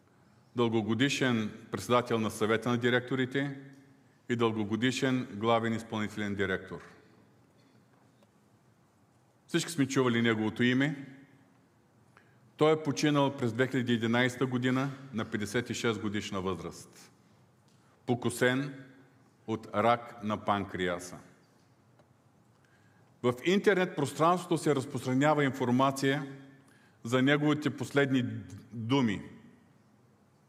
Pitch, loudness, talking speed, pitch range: 125 Hz, -30 LUFS, 80 wpm, 115-135 Hz